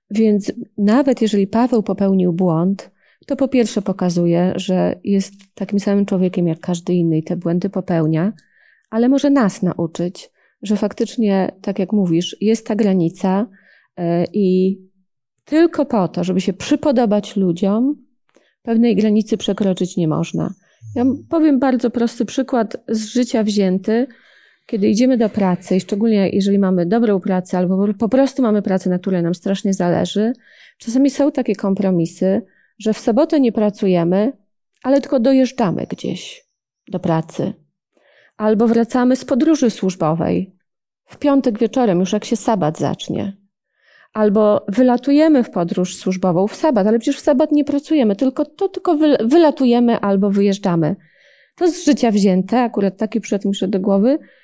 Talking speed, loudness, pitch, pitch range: 150 wpm, -17 LUFS, 210 Hz, 190-250 Hz